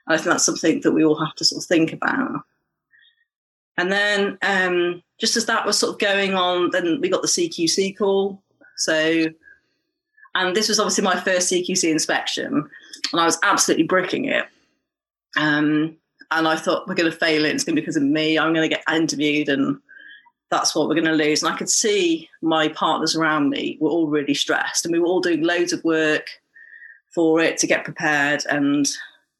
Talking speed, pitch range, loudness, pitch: 205 wpm, 160-225 Hz, -20 LUFS, 175 Hz